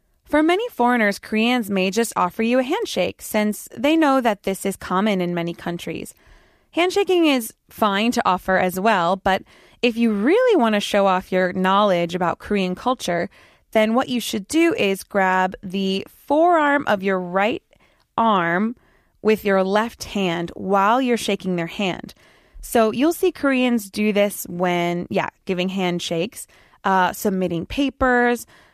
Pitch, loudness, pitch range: 210 Hz, -20 LUFS, 185-245 Hz